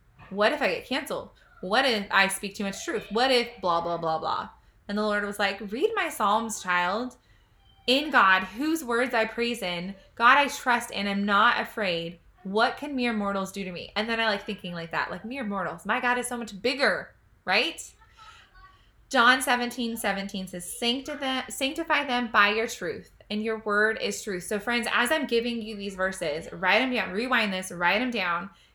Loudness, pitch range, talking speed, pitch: -26 LUFS, 195-245 Hz, 200 wpm, 220 Hz